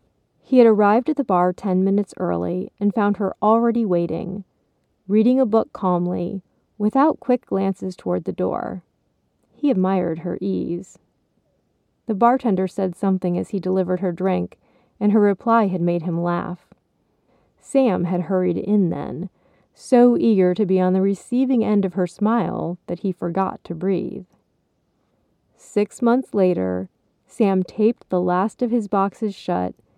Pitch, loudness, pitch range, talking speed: 190 Hz, -20 LUFS, 180-220 Hz, 150 wpm